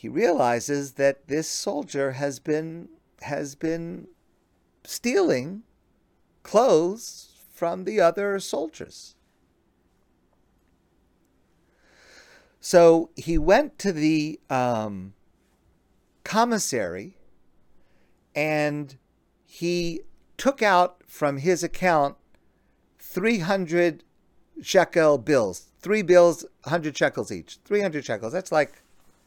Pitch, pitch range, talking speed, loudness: 155 Hz, 135-180 Hz, 90 wpm, -24 LUFS